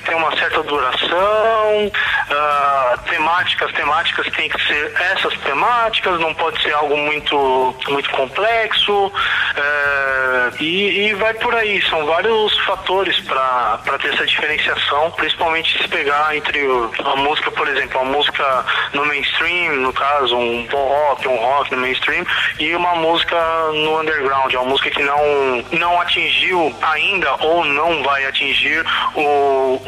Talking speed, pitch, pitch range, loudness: 145 wpm, 150 Hz, 135-175 Hz, -16 LUFS